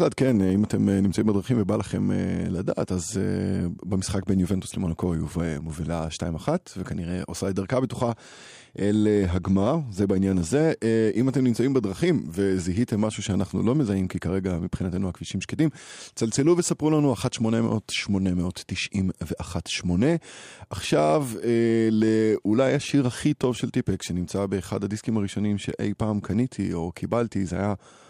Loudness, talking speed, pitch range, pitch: -25 LUFS, 135 wpm, 95-115 Hz, 100 Hz